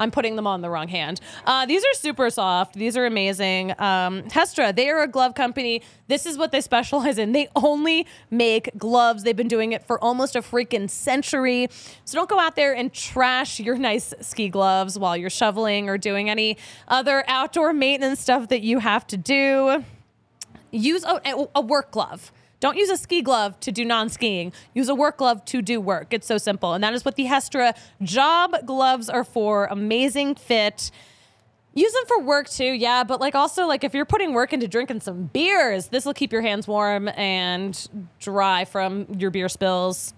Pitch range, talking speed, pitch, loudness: 205-275 Hz, 195 wpm, 245 Hz, -22 LUFS